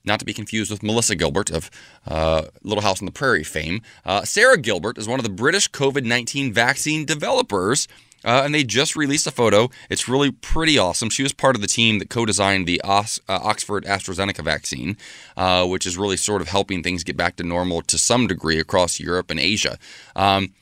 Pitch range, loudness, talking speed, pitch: 90-120 Hz, -20 LUFS, 210 wpm, 100 Hz